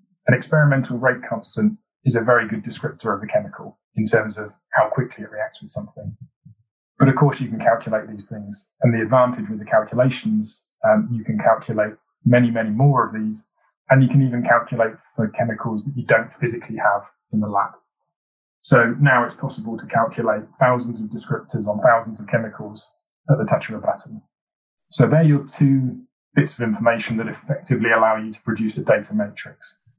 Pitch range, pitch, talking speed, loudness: 110-145 Hz, 120 Hz, 190 wpm, -20 LUFS